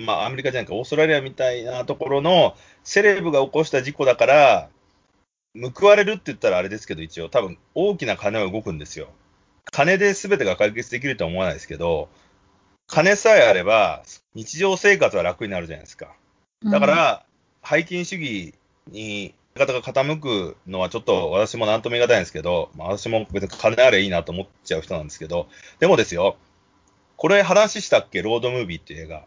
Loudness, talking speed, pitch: -20 LUFS, 400 characters per minute, 125 Hz